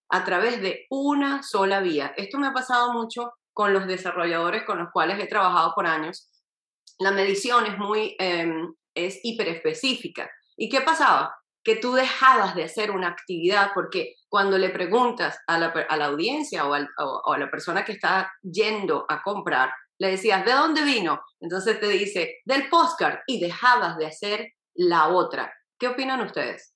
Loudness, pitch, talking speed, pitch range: -24 LUFS, 210 Hz, 175 wpm, 175-260 Hz